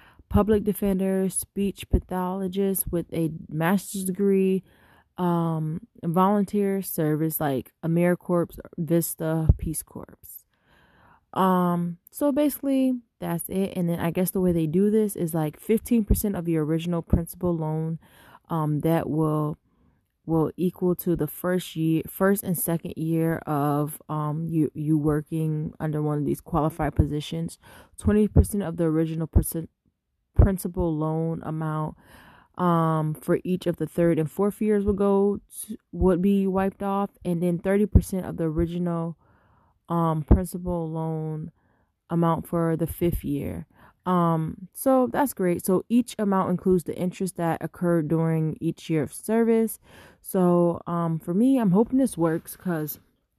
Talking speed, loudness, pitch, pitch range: 140 wpm, -25 LUFS, 170 Hz, 160-190 Hz